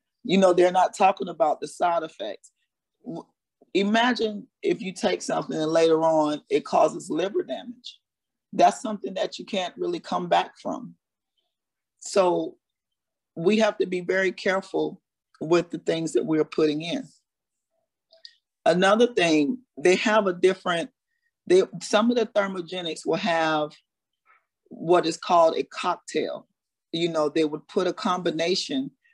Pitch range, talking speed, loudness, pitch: 165-245 Hz, 140 wpm, -24 LUFS, 190 Hz